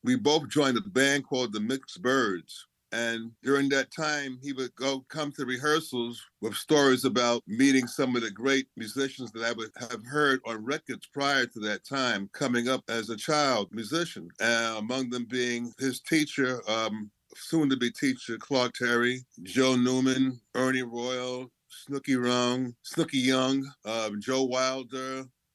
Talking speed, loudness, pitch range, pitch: 155 wpm, -28 LUFS, 120-135 Hz, 130 Hz